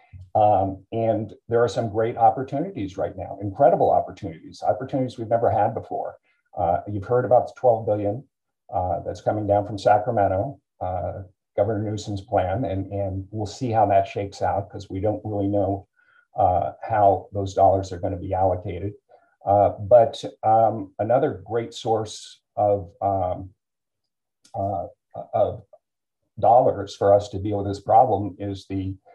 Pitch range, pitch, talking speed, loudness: 95-115 Hz, 100 Hz, 155 wpm, -23 LUFS